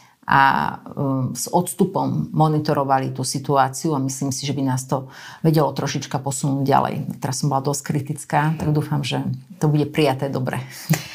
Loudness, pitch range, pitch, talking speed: -21 LUFS, 135-155 Hz, 145 Hz, 155 wpm